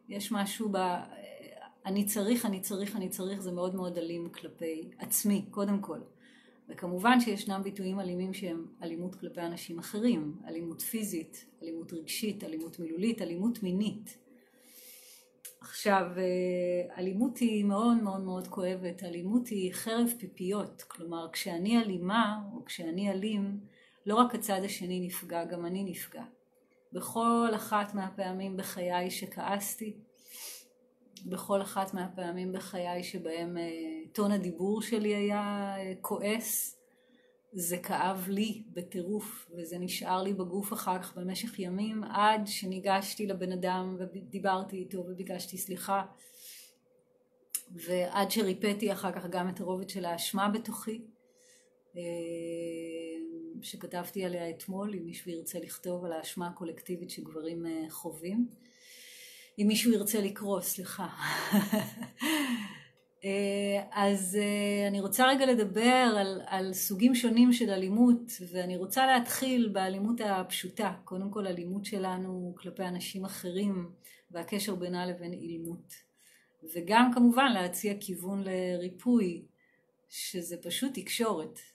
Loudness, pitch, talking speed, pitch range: -32 LUFS, 195 Hz, 115 wpm, 180-215 Hz